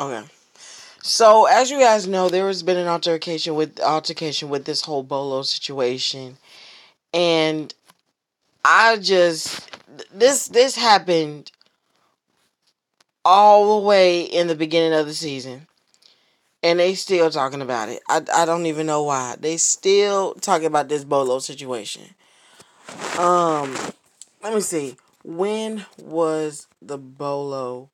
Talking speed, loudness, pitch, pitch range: 130 wpm, -19 LUFS, 160 Hz, 140-185 Hz